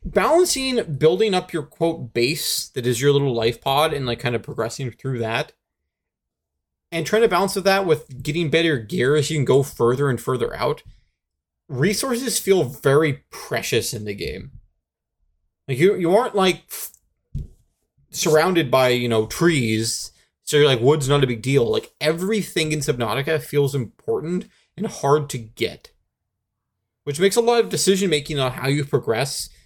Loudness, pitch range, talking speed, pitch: -20 LUFS, 120-175 Hz, 170 wpm, 145 Hz